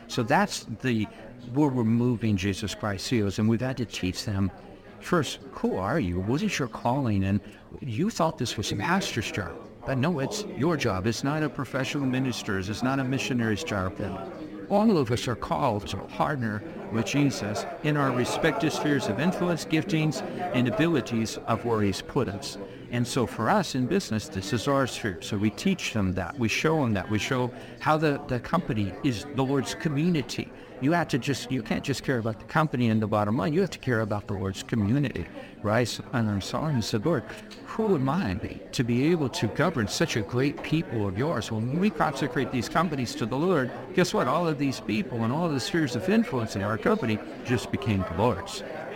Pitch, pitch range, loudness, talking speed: 125 Hz, 110-145 Hz, -27 LUFS, 205 wpm